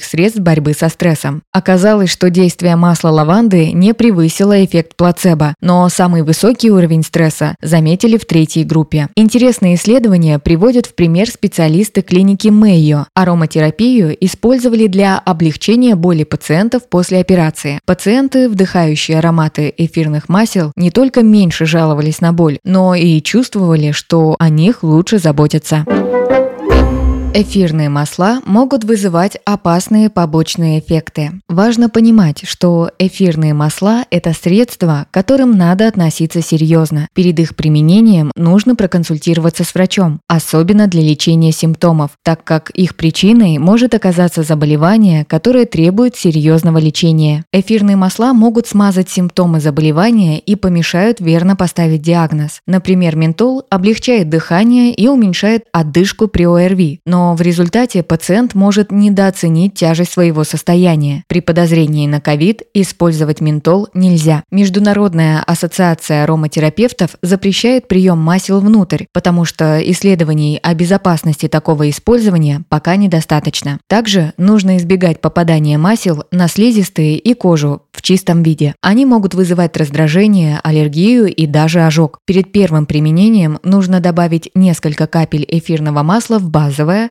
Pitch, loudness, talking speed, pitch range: 175 Hz, -11 LUFS, 125 wpm, 160-200 Hz